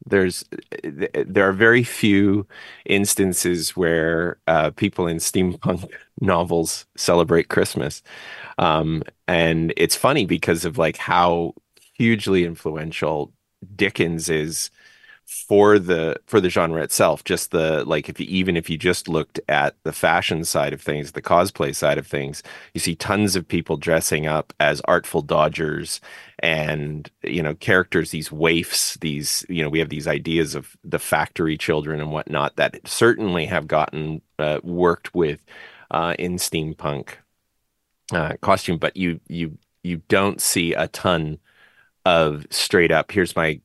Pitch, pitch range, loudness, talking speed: 85 Hz, 80-90 Hz, -21 LUFS, 145 wpm